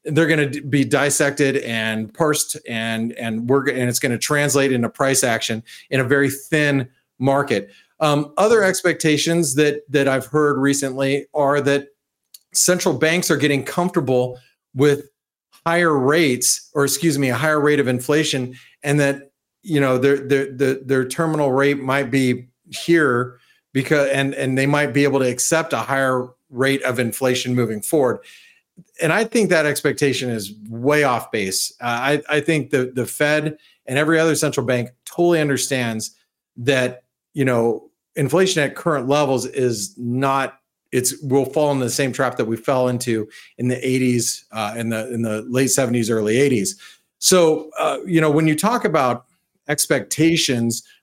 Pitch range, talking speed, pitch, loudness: 125-150 Hz, 165 wpm, 140 Hz, -19 LUFS